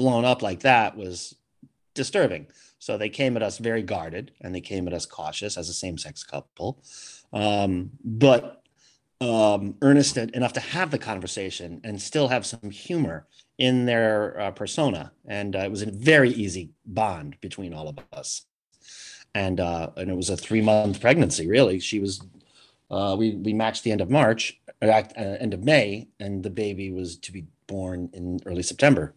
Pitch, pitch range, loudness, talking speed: 105 Hz, 95-115 Hz, -24 LUFS, 175 wpm